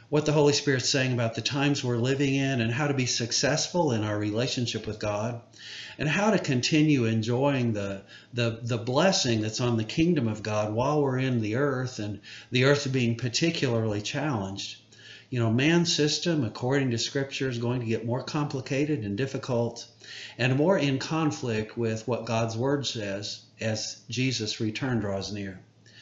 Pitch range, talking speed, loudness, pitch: 110-140 Hz, 175 wpm, -27 LUFS, 120 Hz